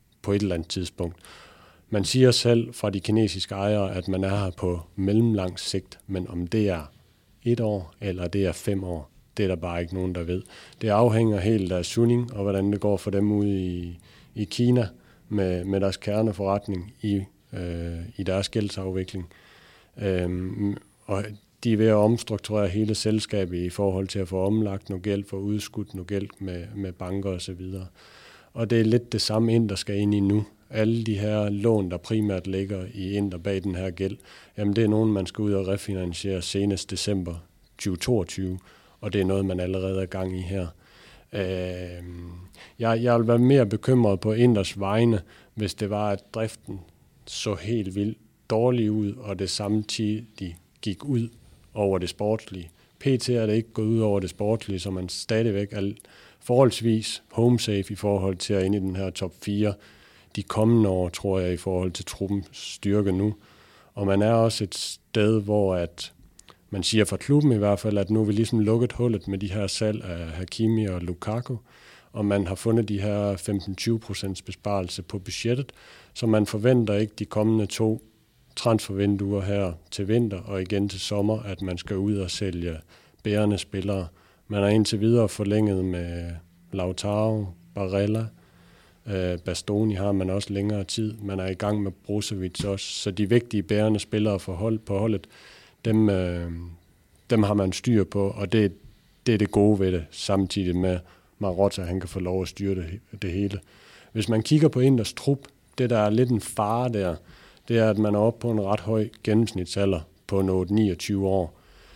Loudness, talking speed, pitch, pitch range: -25 LUFS, 185 wpm, 100 Hz, 95-110 Hz